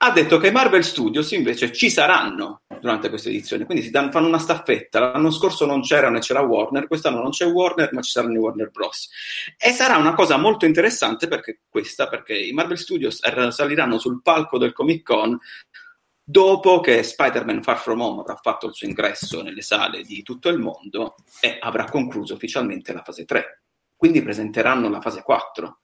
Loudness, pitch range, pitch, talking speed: -20 LUFS, 140-215 Hz, 165 Hz, 190 wpm